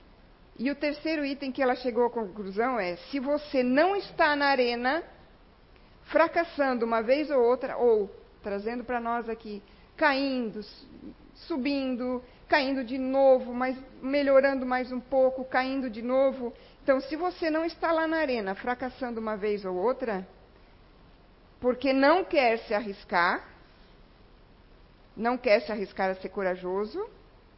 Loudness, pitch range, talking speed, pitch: -28 LUFS, 230-280 Hz, 140 wpm, 255 Hz